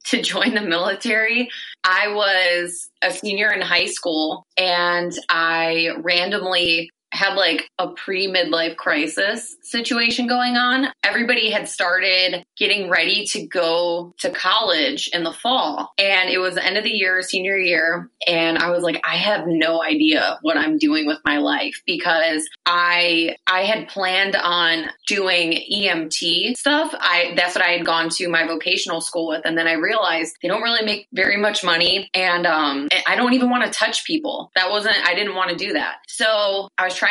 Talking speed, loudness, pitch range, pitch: 180 wpm, -18 LUFS, 170-215 Hz, 185 Hz